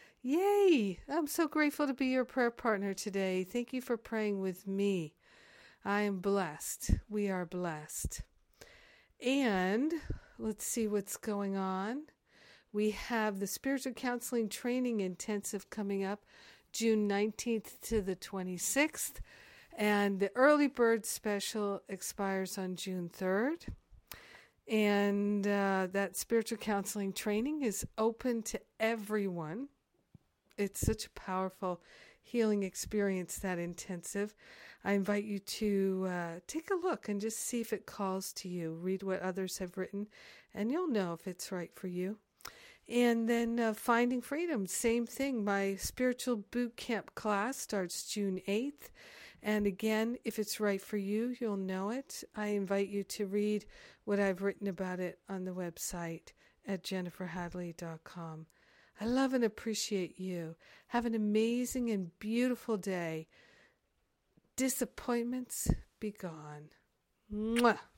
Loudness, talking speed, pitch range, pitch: -35 LUFS, 135 wpm, 190-235 Hz, 205 Hz